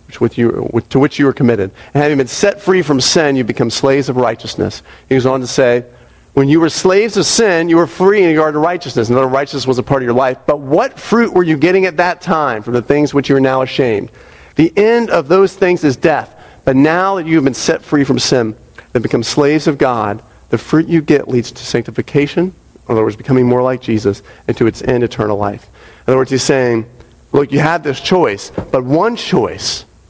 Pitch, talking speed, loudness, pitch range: 135 Hz, 230 wpm, -13 LUFS, 120-160 Hz